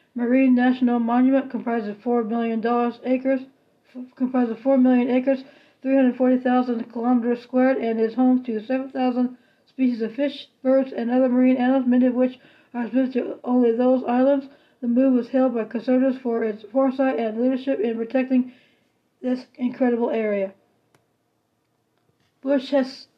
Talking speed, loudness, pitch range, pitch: 150 wpm, -22 LUFS, 240-265 Hz, 255 Hz